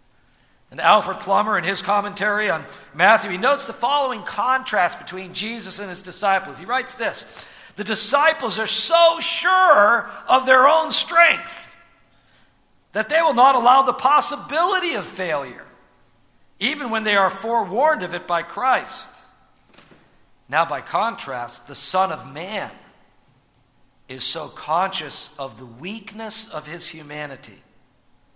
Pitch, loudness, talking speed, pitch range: 220 Hz, -19 LUFS, 135 wpm, 185-270 Hz